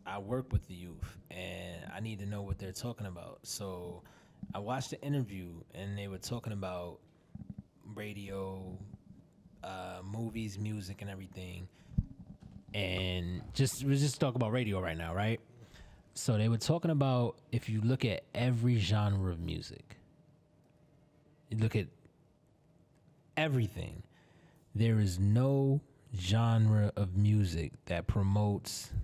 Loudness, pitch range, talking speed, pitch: -35 LUFS, 95-120 Hz, 135 wpm, 105 Hz